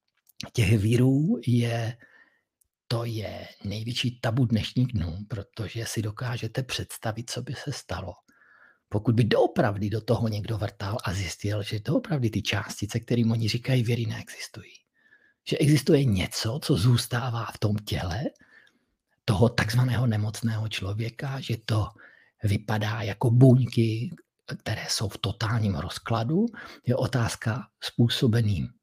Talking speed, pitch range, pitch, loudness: 125 wpm, 105-125 Hz, 115 Hz, -27 LUFS